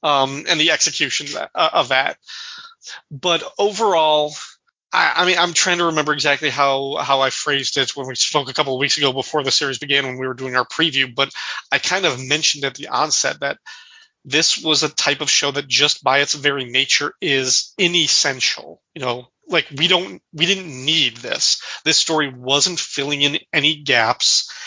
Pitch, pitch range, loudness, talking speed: 145 Hz, 135-160 Hz, -17 LUFS, 190 wpm